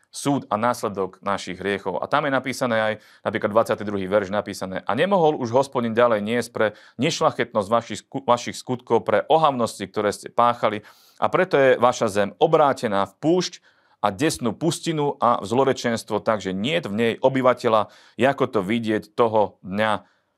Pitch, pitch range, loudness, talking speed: 115 Hz, 105-130 Hz, -22 LUFS, 155 wpm